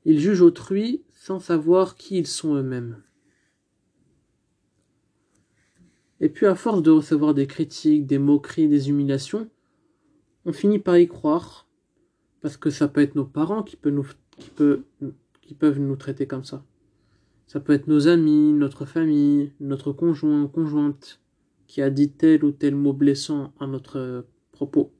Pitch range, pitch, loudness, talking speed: 140-170 Hz, 150 Hz, -21 LUFS, 155 wpm